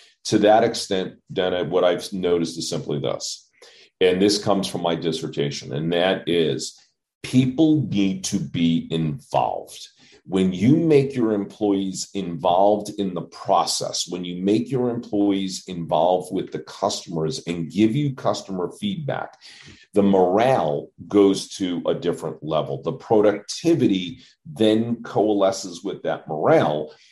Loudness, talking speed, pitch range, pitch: -22 LUFS, 135 wpm, 90-110 Hz, 100 Hz